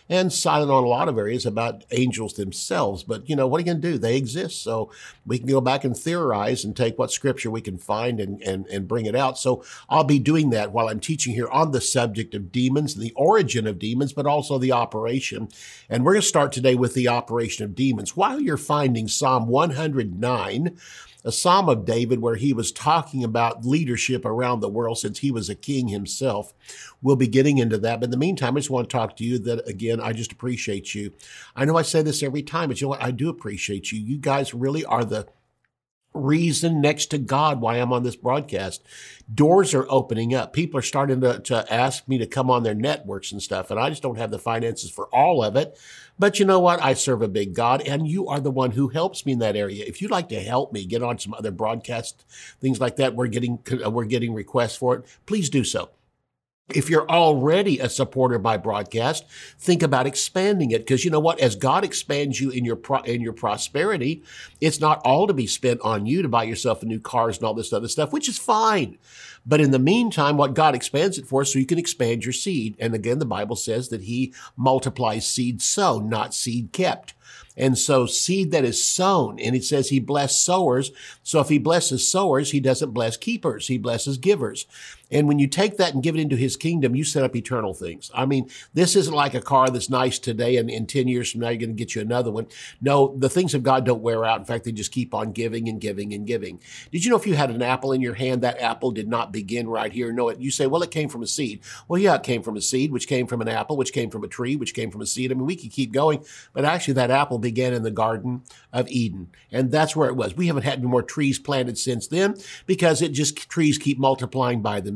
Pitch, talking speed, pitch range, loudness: 130 Hz, 245 wpm, 115-145 Hz, -22 LUFS